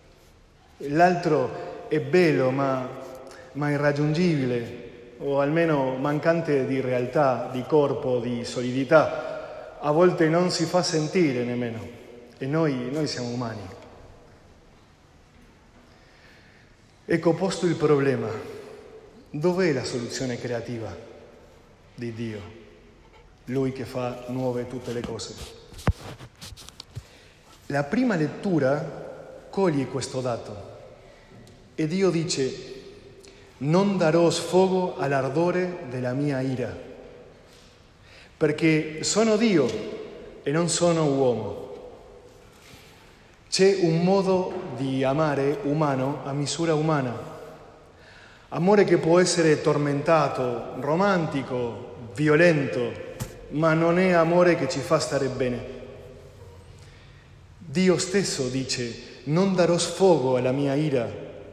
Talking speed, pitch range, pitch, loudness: 100 wpm, 125-170 Hz, 140 Hz, -24 LUFS